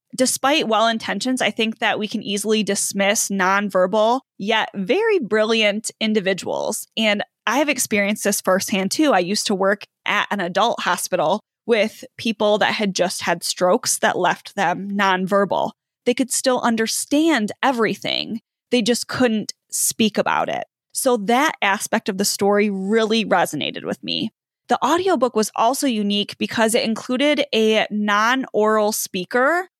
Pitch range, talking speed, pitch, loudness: 200-245 Hz, 150 wpm, 220 Hz, -19 LUFS